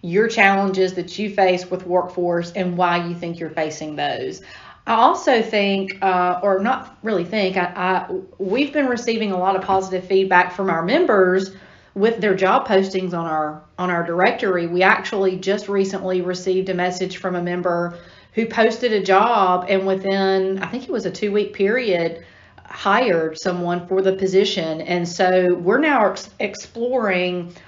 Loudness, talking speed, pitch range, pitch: -19 LUFS, 170 wpm, 180-200 Hz, 190 Hz